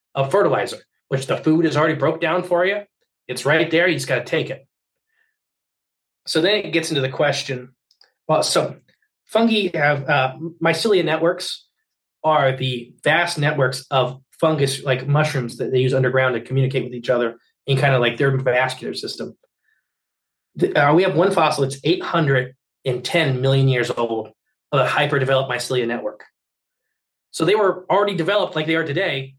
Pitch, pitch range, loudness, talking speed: 140 Hz, 130-170 Hz, -19 LUFS, 170 wpm